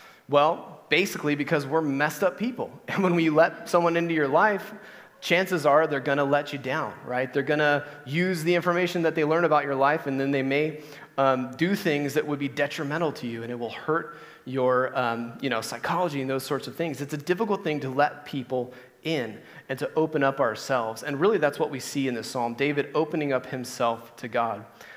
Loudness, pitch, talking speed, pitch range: -26 LUFS, 145 Hz, 220 wpm, 130-165 Hz